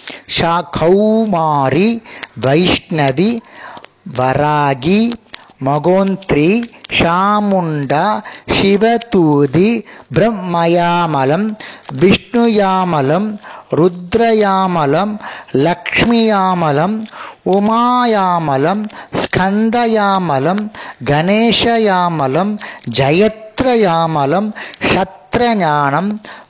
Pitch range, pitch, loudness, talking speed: 160-215 Hz, 185 Hz, -13 LUFS, 35 wpm